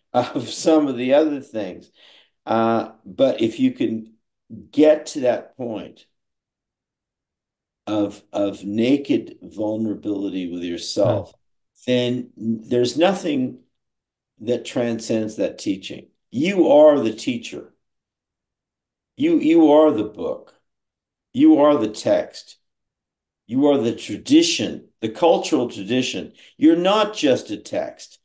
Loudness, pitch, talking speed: -20 LUFS, 130 Hz, 115 wpm